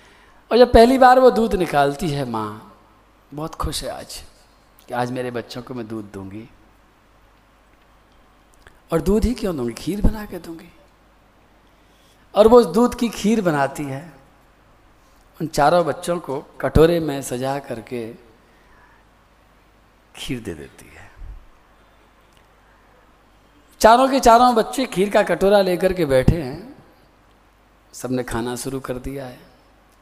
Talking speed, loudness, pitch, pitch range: 135 wpm, -18 LUFS, 145 Hz, 125-210 Hz